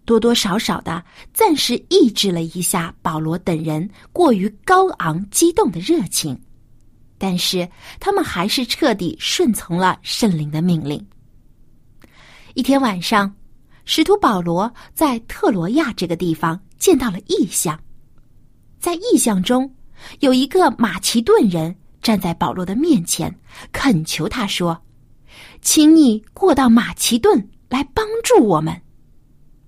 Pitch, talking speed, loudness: 215 Hz, 195 characters per minute, -17 LUFS